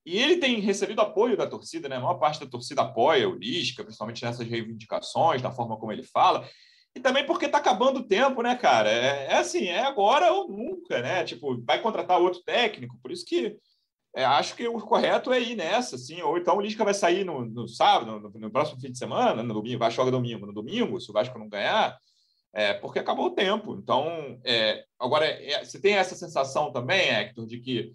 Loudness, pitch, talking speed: -26 LUFS, 195 Hz, 220 wpm